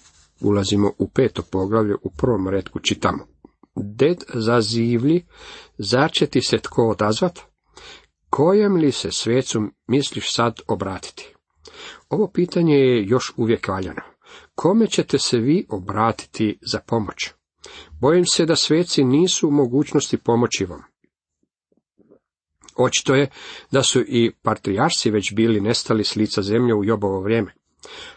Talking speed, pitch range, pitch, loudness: 130 wpm, 105-150 Hz, 120 Hz, -20 LUFS